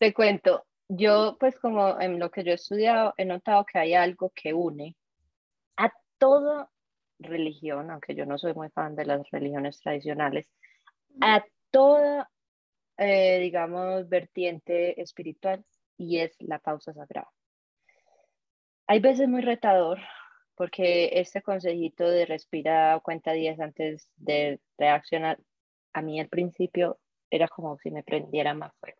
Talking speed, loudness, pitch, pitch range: 140 wpm, -26 LUFS, 175 Hz, 155-200 Hz